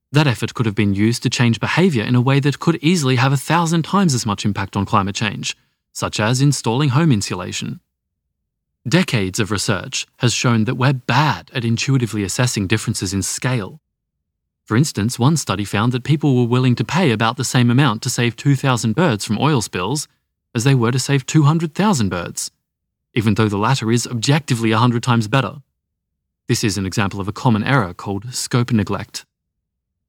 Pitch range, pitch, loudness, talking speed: 105-135 Hz, 120 Hz, -18 LUFS, 185 wpm